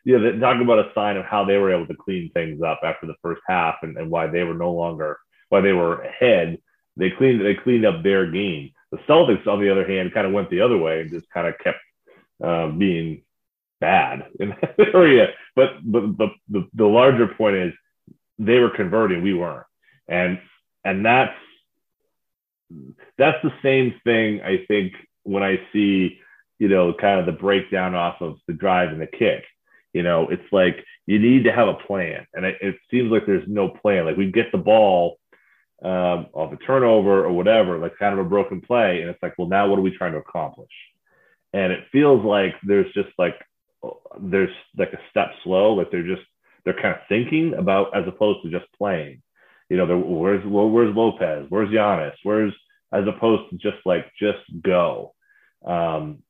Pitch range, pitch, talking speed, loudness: 90-110 Hz, 100 Hz, 200 wpm, -20 LUFS